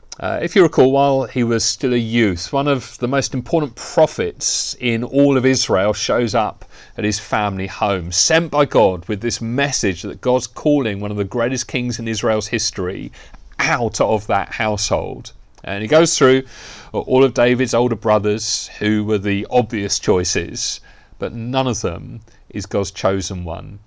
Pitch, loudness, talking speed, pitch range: 115 Hz, -18 LUFS, 175 wpm, 105-130 Hz